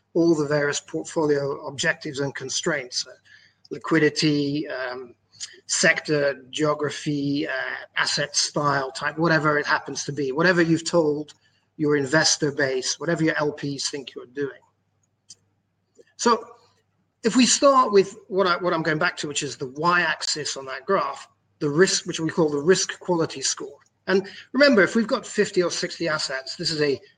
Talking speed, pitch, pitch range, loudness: 165 wpm, 155 Hz, 140-175 Hz, -23 LUFS